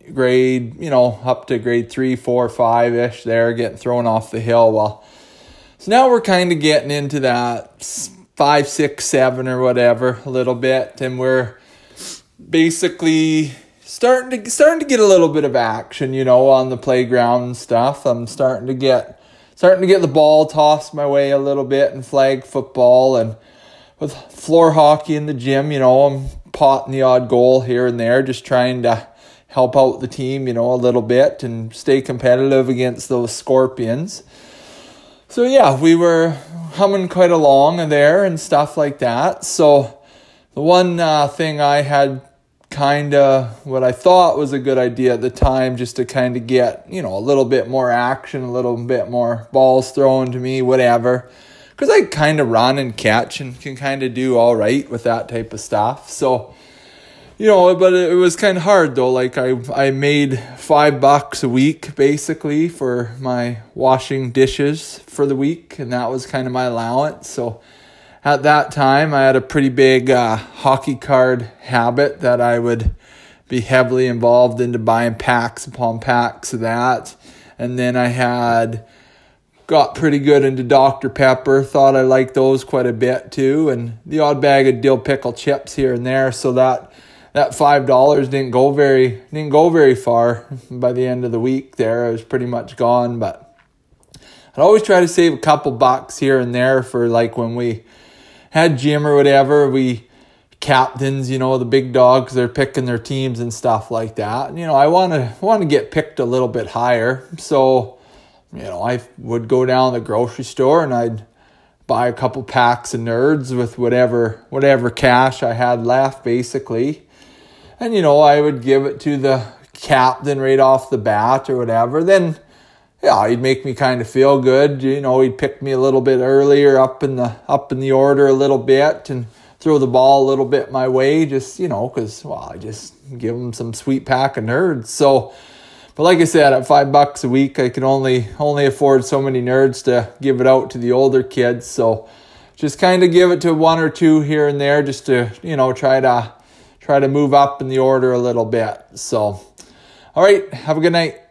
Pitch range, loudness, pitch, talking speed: 125-145 Hz, -15 LUFS, 130 Hz, 195 wpm